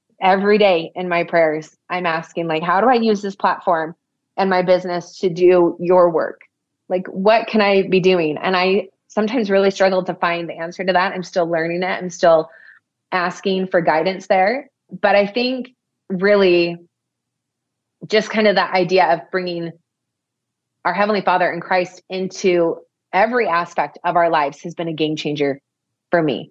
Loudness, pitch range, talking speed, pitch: -18 LUFS, 170-195 Hz, 175 wpm, 180 Hz